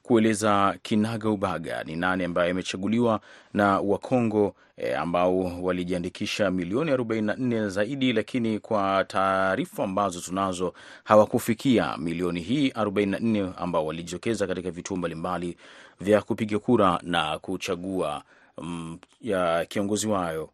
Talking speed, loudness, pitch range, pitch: 100 wpm, -26 LUFS, 90-110 Hz, 95 Hz